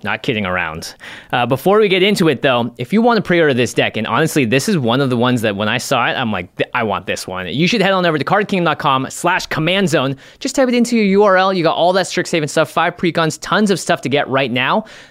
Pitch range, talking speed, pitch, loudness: 130-190 Hz, 270 wpm, 160 Hz, -15 LUFS